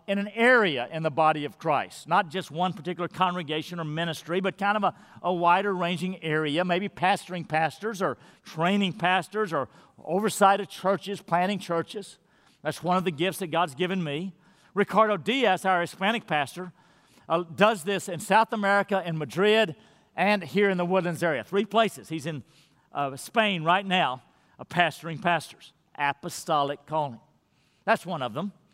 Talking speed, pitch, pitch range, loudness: 165 wpm, 180 Hz, 160-195 Hz, -26 LUFS